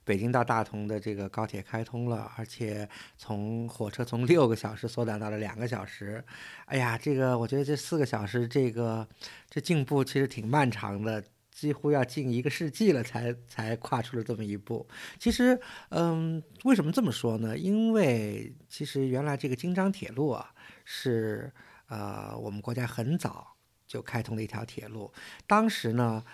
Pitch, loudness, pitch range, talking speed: 120 Hz, -30 LUFS, 110-145 Hz, 260 characters per minute